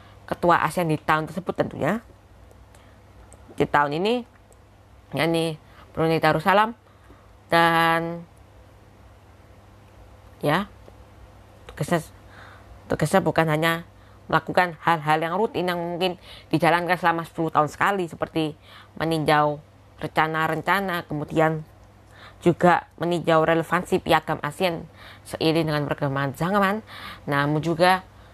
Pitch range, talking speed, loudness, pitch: 100-170 Hz, 95 wpm, -23 LUFS, 155 Hz